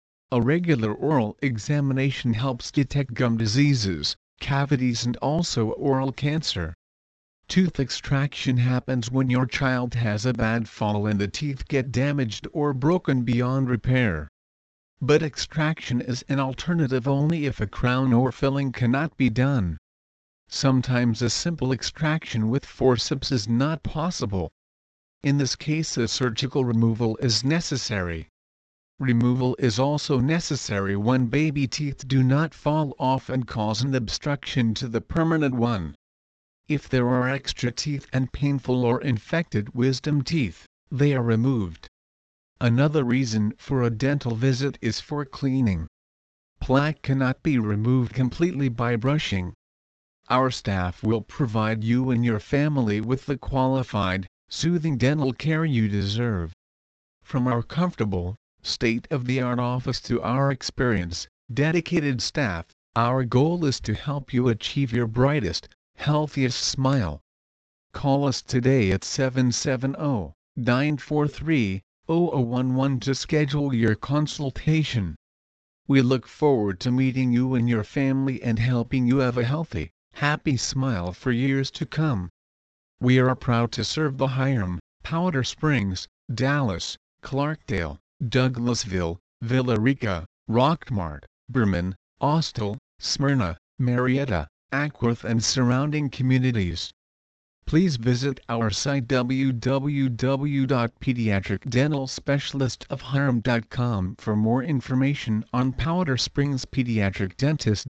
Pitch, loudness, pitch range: 125 Hz, -24 LUFS, 110-140 Hz